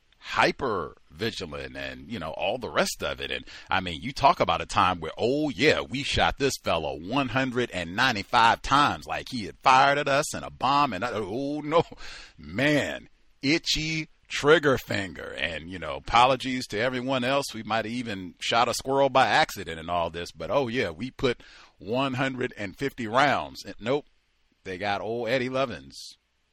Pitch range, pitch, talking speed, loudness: 105-135 Hz, 130 Hz, 175 wpm, -26 LUFS